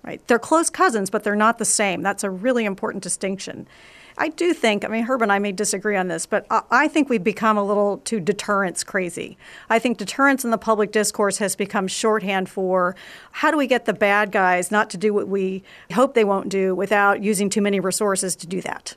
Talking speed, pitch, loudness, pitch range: 225 wpm, 205 Hz, -20 LUFS, 195-225 Hz